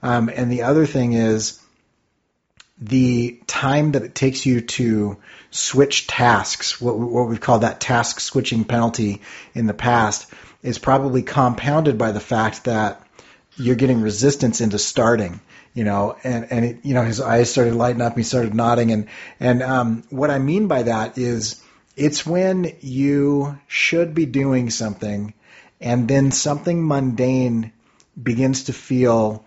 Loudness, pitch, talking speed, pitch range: -19 LUFS, 120 Hz, 155 wpm, 115-135 Hz